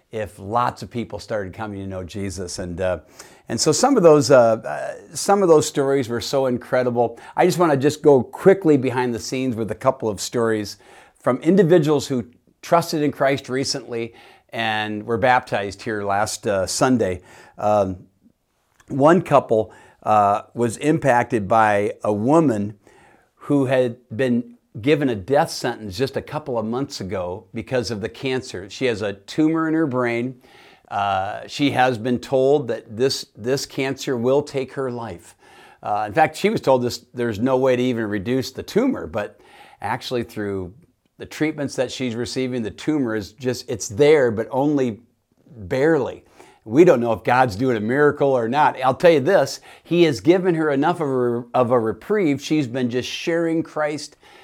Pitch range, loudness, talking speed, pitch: 115-140 Hz, -20 LUFS, 175 wpm, 125 Hz